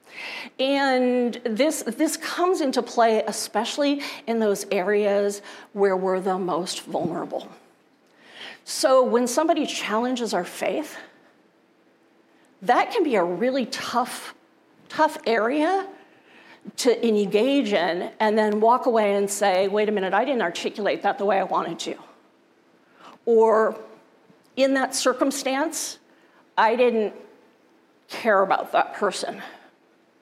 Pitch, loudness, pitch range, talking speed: 235 Hz, -23 LUFS, 210-280 Hz, 120 wpm